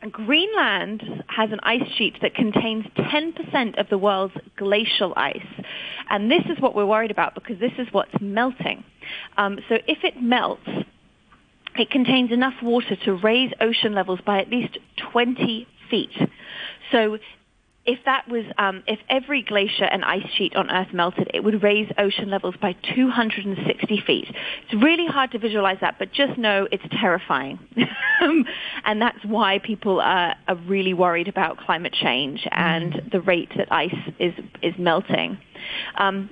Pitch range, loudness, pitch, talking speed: 195-245 Hz, -22 LUFS, 215 Hz, 160 wpm